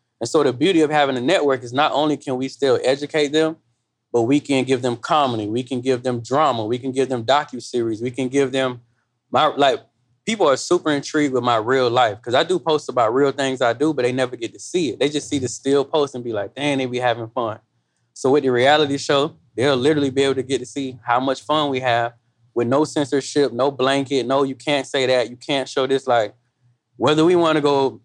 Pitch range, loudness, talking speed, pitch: 125-145 Hz, -20 LUFS, 245 wpm, 135 Hz